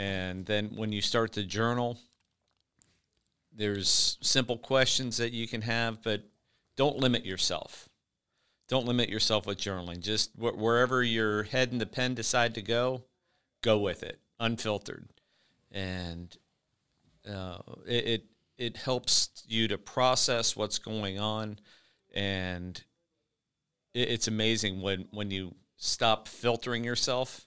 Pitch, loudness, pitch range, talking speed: 115 Hz, -30 LUFS, 100-120 Hz, 130 wpm